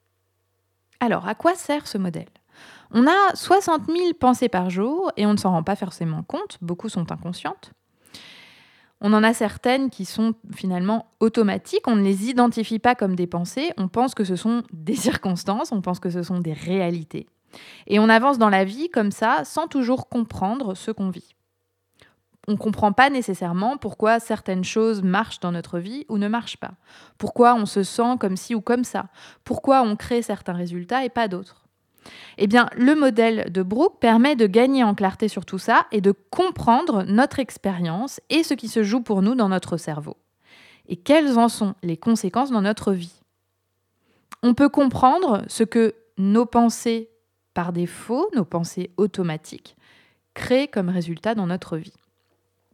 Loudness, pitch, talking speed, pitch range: -21 LUFS, 215 Hz, 180 wpm, 180-240 Hz